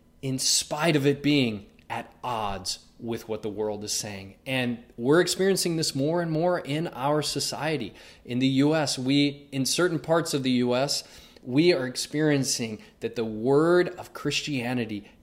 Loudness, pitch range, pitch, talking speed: -26 LUFS, 115-150 Hz, 135 Hz, 160 wpm